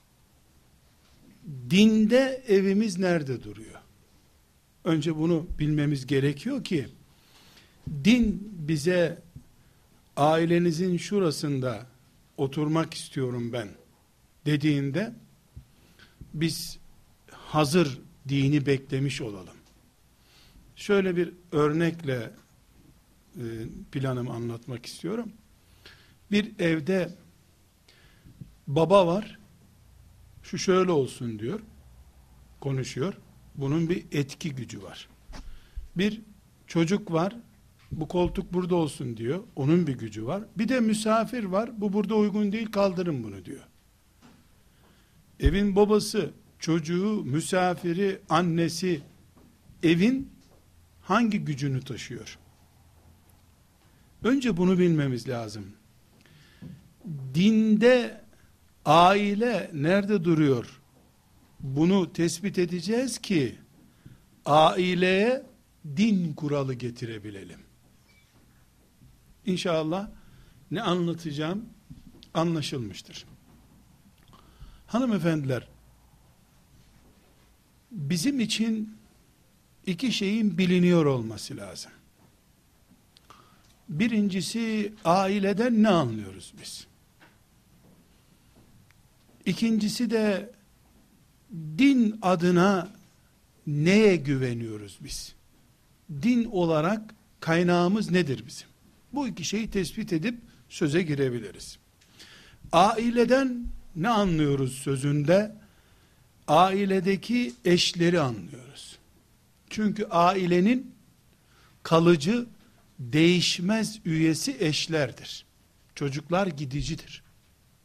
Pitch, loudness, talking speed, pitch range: 170 Hz, -26 LUFS, 70 wpm, 135-200 Hz